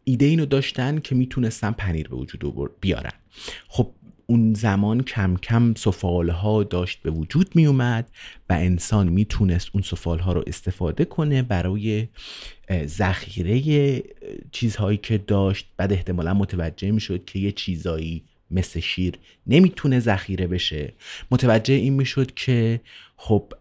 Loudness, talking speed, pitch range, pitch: -22 LUFS, 125 wpm, 90-125 Hz, 100 Hz